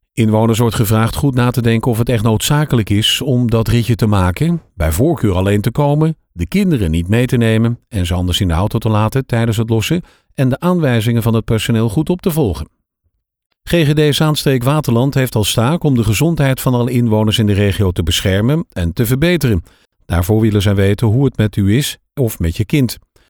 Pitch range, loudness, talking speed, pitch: 105-135 Hz, -14 LUFS, 210 wpm, 115 Hz